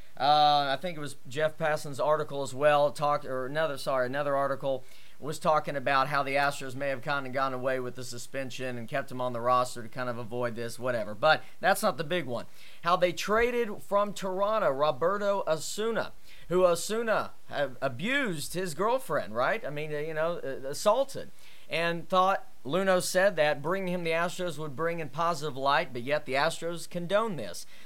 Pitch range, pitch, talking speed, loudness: 135-180 Hz, 150 Hz, 185 wpm, -29 LUFS